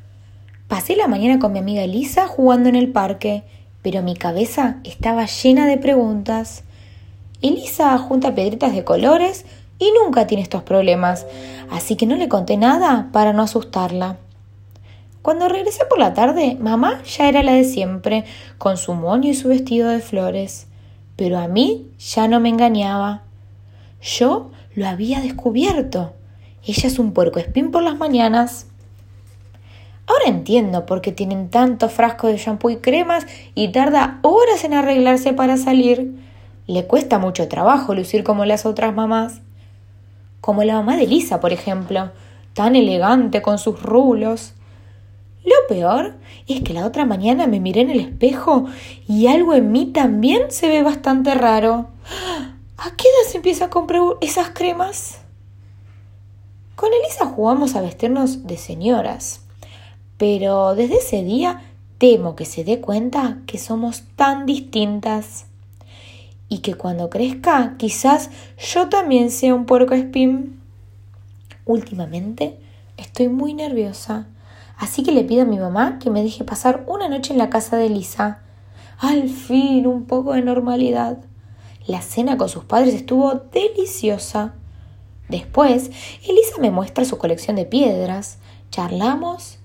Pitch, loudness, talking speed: 220 Hz, -17 LUFS, 145 wpm